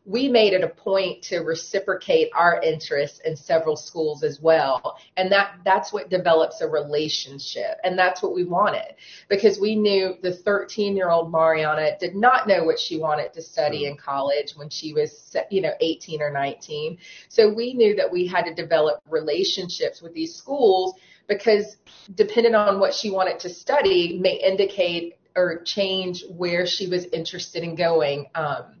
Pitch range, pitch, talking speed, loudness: 160-200 Hz, 180 Hz, 175 wpm, -22 LUFS